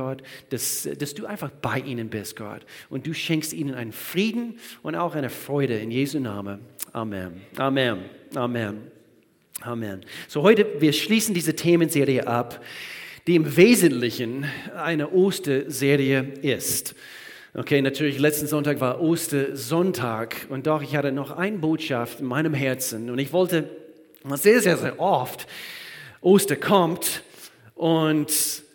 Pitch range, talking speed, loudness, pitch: 130-160 Hz, 135 wpm, -23 LUFS, 145 Hz